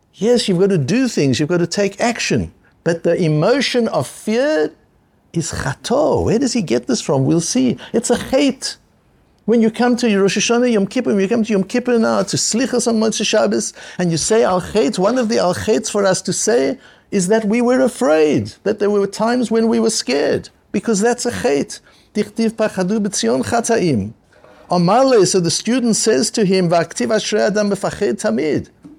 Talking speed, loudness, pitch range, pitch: 180 wpm, -16 LUFS, 190-235 Hz, 215 Hz